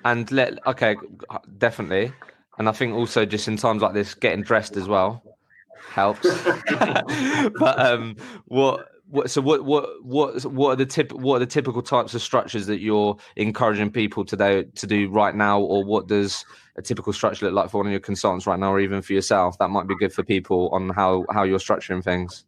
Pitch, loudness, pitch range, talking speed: 105 Hz, -22 LUFS, 100-120 Hz, 205 wpm